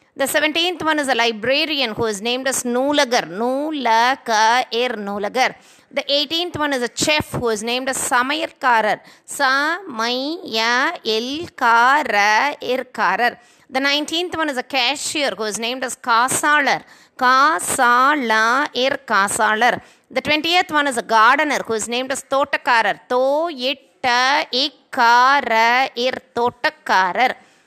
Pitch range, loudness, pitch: 235-290 Hz, -18 LUFS, 255 Hz